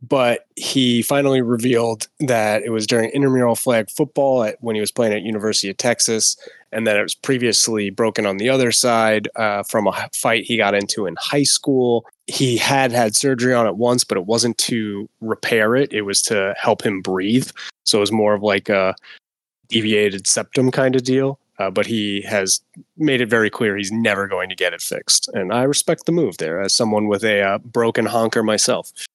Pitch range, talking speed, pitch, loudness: 105-125 Hz, 205 wpm, 115 Hz, -18 LUFS